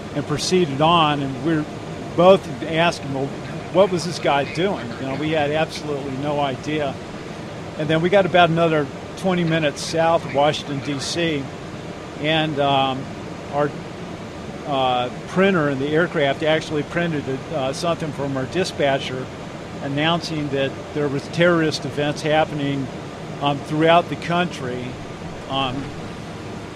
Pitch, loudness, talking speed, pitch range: 150 Hz, -21 LUFS, 130 wpm, 140-170 Hz